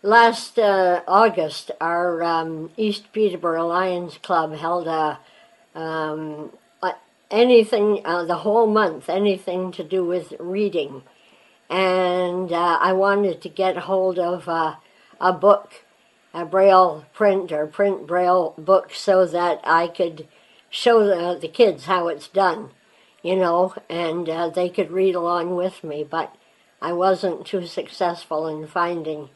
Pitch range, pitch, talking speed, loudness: 165-195 Hz, 180 Hz, 140 wpm, -21 LUFS